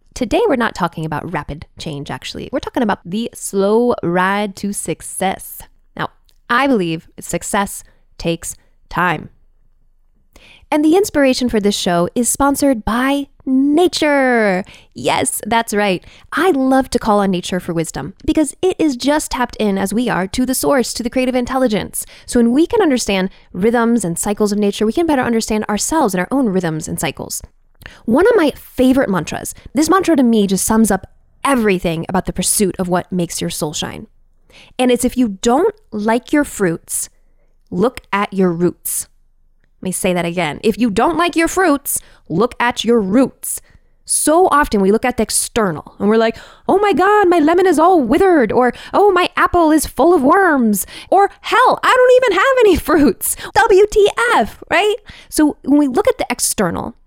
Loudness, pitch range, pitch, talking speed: -15 LUFS, 195-300 Hz, 235 Hz, 180 wpm